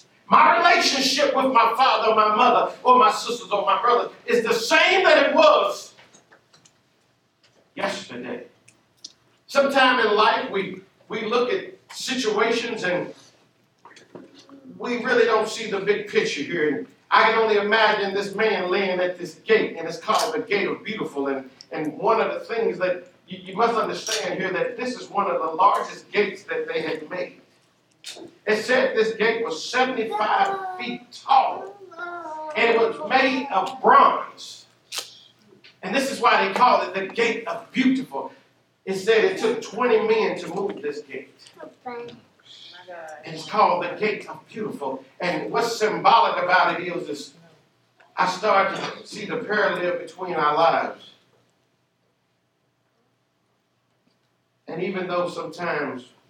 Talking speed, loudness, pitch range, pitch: 150 wpm, -21 LUFS, 180-260 Hz, 220 Hz